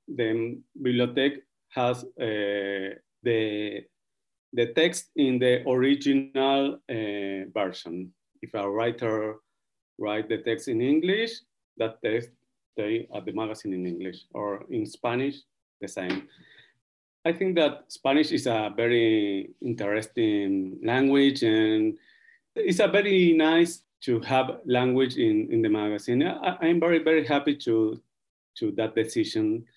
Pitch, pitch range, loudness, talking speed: 125 Hz, 110-165 Hz, -26 LUFS, 125 wpm